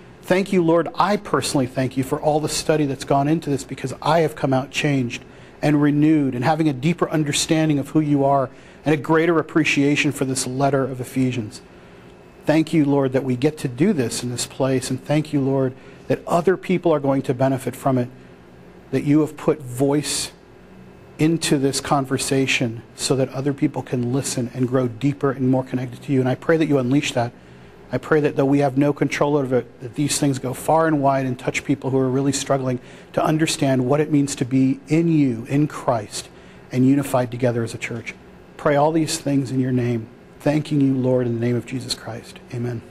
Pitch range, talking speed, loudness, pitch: 130-150 Hz, 215 wpm, -20 LUFS, 140 Hz